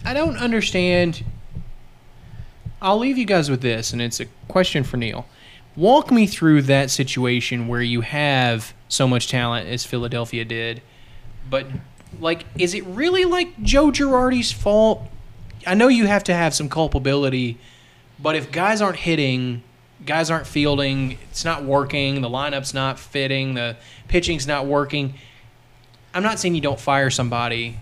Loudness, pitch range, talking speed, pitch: -20 LUFS, 120-175 Hz, 155 wpm, 135 Hz